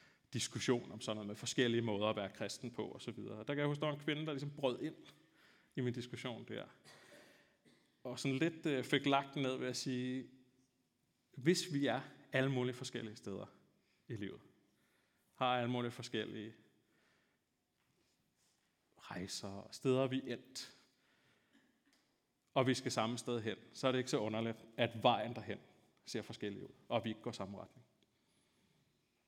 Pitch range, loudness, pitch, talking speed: 115-135 Hz, -40 LUFS, 125 Hz, 165 wpm